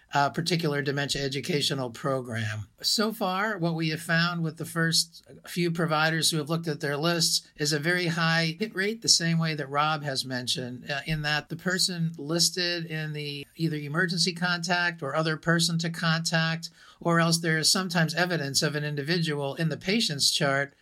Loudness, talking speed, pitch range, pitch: -26 LUFS, 185 wpm, 145-170 Hz, 160 Hz